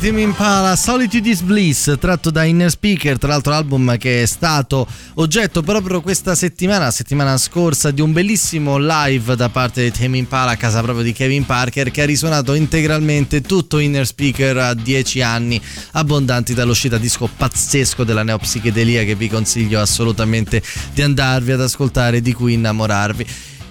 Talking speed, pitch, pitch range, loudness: 160 wpm, 135 Hz, 120-155 Hz, -15 LUFS